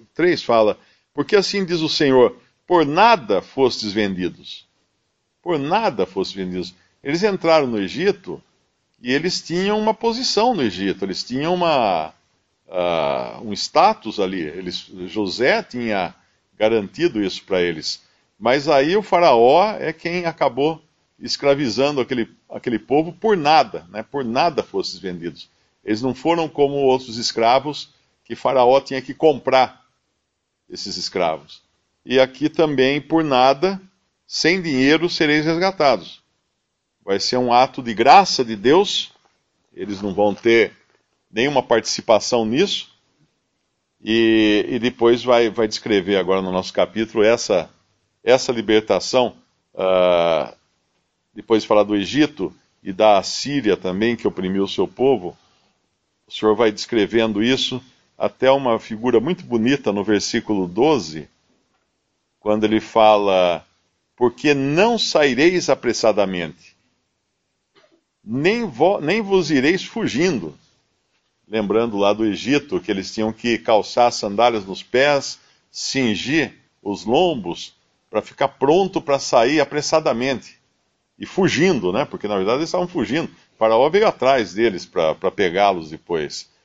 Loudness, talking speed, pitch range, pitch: -19 LUFS, 130 wpm, 105-150 Hz, 120 Hz